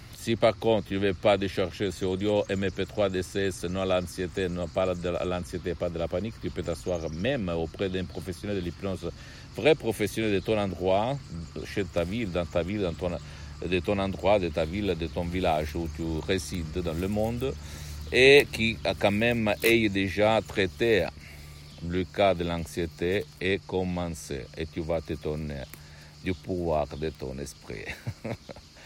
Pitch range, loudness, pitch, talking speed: 80-100 Hz, -28 LUFS, 90 Hz, 175 wpm